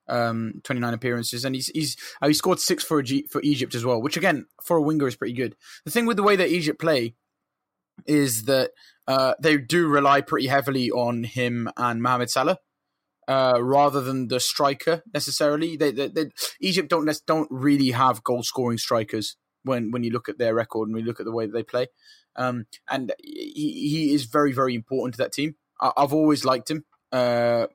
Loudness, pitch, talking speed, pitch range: -24 LUFS, 140 Hz, 200 wpm, 125-150 Hz